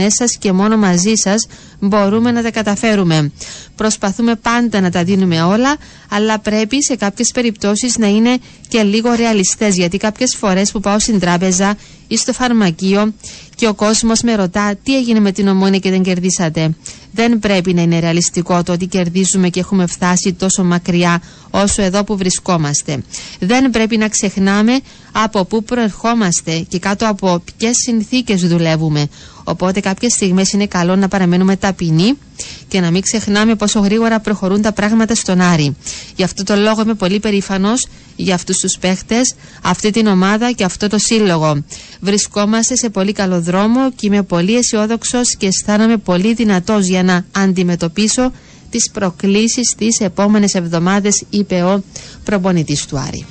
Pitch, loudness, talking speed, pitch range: 200 Hz, -14 LUFS, 160 wpm, 185-220 Hz